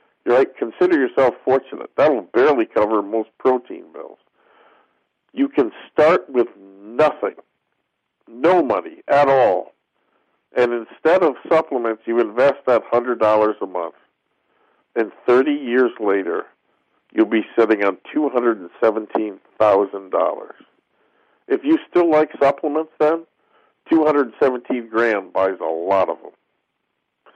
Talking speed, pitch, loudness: 135 wpm, 130 Hz, -19 LUFS